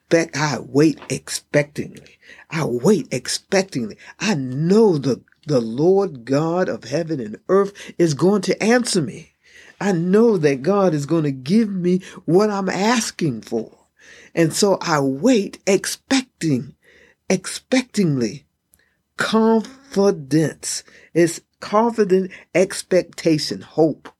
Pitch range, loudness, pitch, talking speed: 155-210 Hz, -20 LUFS, 180 Hz, 110 wpm